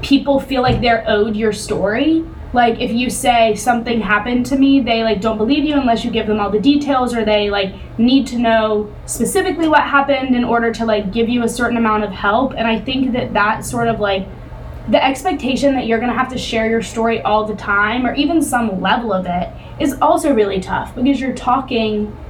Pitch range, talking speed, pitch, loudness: 215-265 Hz, 220 wpm, 235 Hz, -16 LUFS